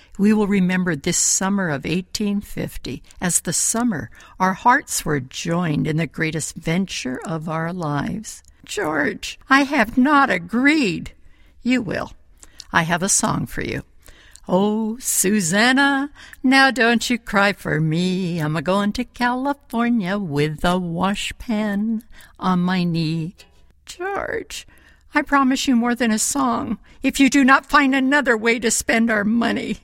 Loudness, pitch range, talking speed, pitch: -19 LUFS, 175-245 Hz, 145 wpm, 210 Hz